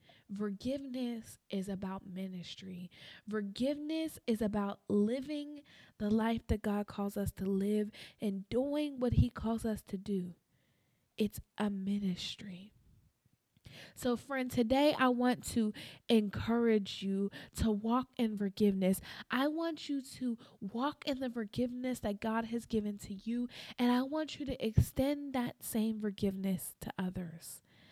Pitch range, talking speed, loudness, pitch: 200-250 Hz, 140 wpm, -36 LUFS, 220 Hz